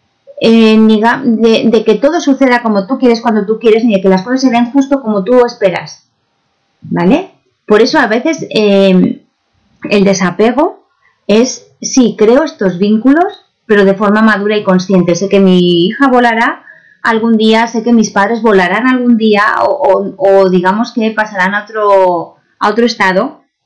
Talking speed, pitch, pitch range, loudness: 175 wpm, 220 Hz, 200-240 Hz, -9 LUFS